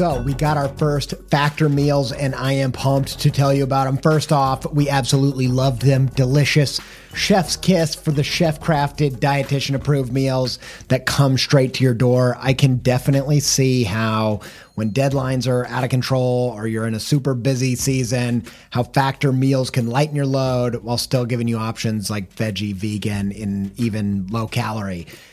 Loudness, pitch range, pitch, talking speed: -19 LUFS, 120-140 Hz, 135 Hz, 175 wpm